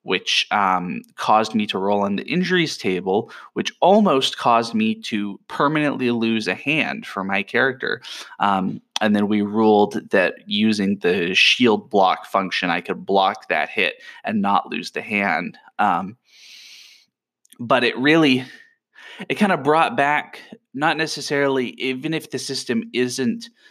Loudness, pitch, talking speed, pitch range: -20 LUFS, 130 Hz, 150 wpm, 110-160 Hz